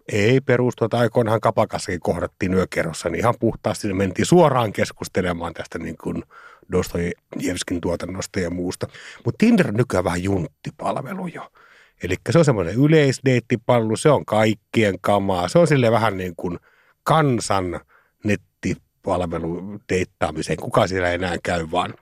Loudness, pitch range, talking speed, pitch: -21 LUFS, 90-120 Hz, 140 wpm, 105 Hz